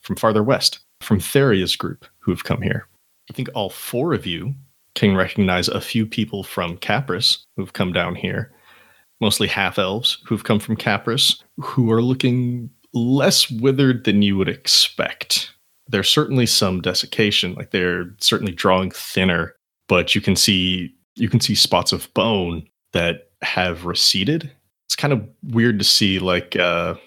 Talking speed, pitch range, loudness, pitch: 160 wpm, 95-120 Hz, -19 LUFS, 105 Hz